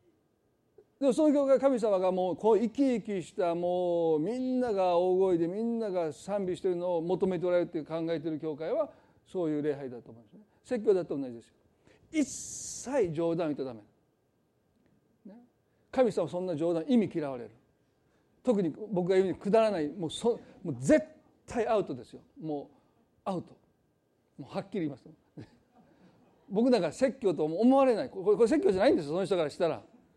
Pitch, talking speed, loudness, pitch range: 185 Hz, 350 characters per minute, -30 LUFS, 165-240 Hz